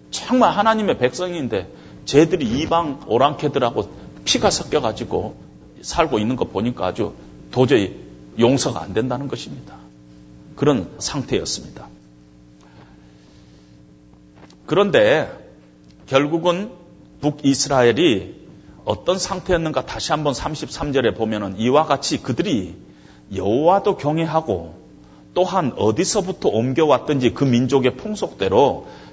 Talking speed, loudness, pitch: 255 characters per minute, -19 LUFS, 120 Hz